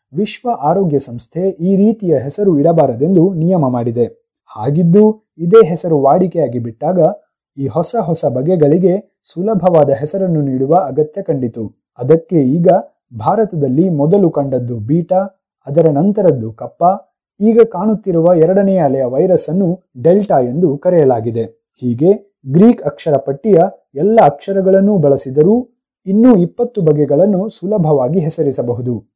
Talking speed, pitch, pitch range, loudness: 110 wpm, 170 Hz, 140-195 Hz, -13 LUFS